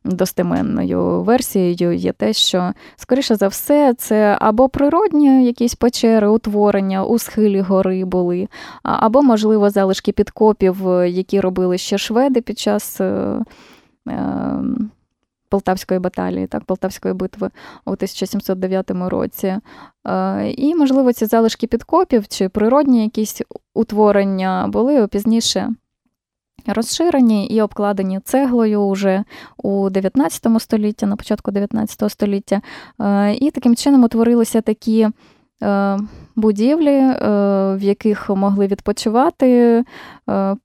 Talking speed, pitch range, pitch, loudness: 105 wpm, 195-235 Hz, 210 Hz, -16 LUFS